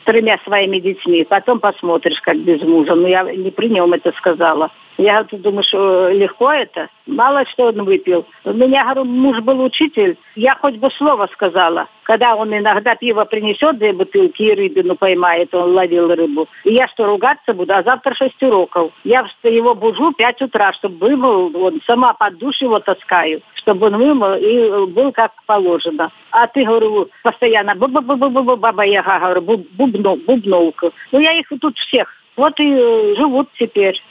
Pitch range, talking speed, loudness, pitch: 185-265 Hz, 180 wpm, -14 LUFS, 215 Hz